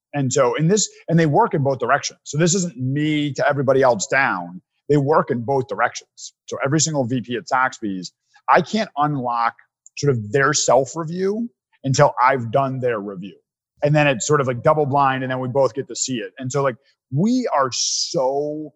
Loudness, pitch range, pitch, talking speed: -19 LUFS, 130-160 Hz, 140 Hz, 200 wpm